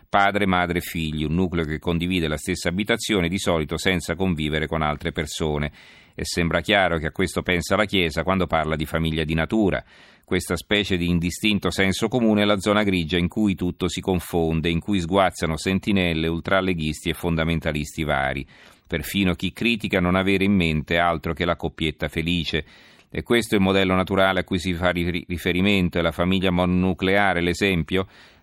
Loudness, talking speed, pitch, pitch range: -22 LUFS, 175 wpm, 90 Hz, 80-95 Hz